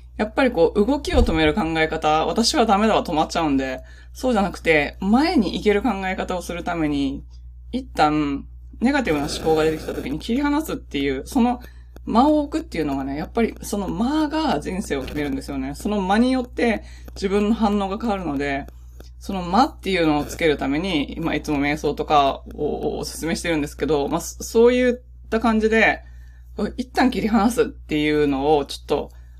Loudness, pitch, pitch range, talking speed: -21 LUFS, 165 Hz, 140-230 Hz, 380 characters per minute